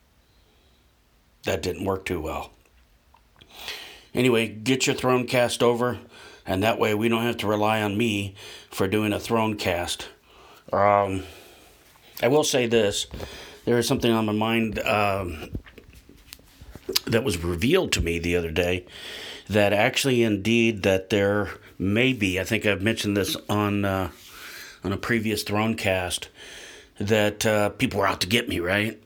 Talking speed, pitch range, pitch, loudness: 155 wpm, 95-115 Hz, 105 Hz, -24 LUFS